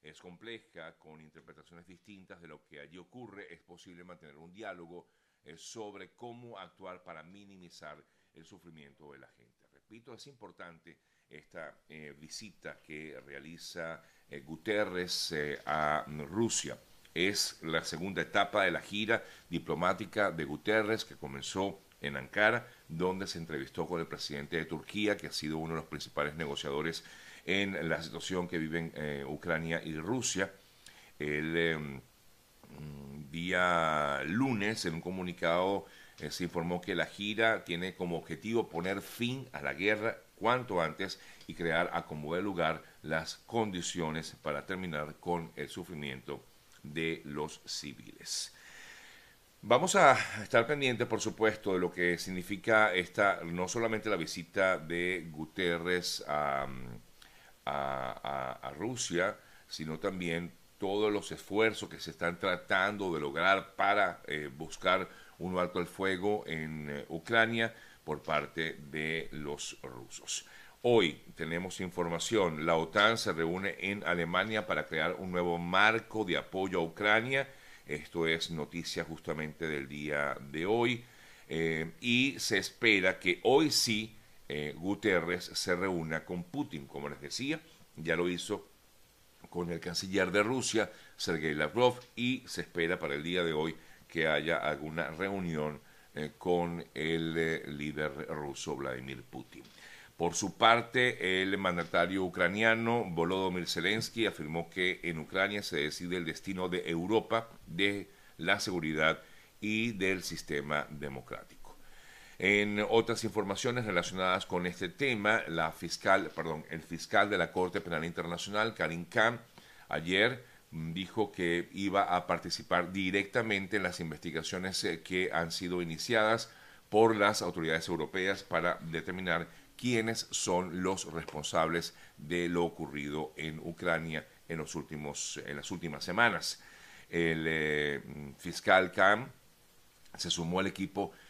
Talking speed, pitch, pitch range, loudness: 140 wpm, 85 Hz, 80-100 Hz, -33 LUFS